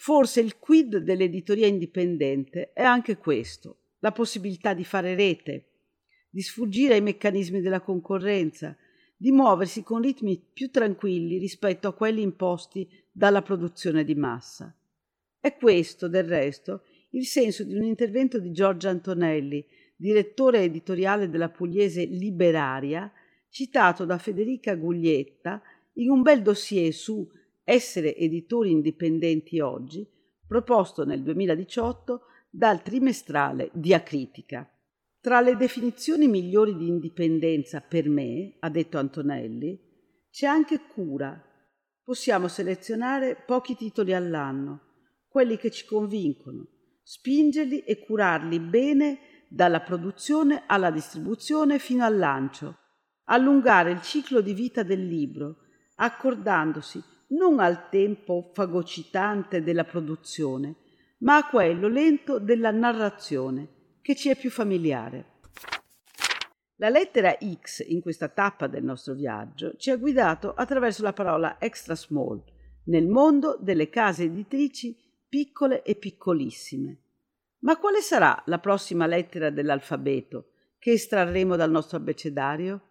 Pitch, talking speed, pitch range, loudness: 195 Hz, 120 wpm, 165-240 Hz, -25 LUFS